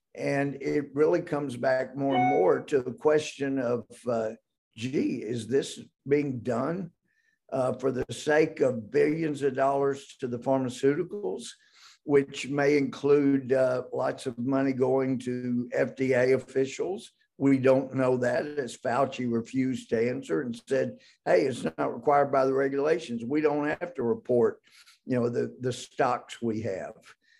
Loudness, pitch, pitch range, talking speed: -28 LUFS, 135 Hz, 125-145 Hz, 155 wpm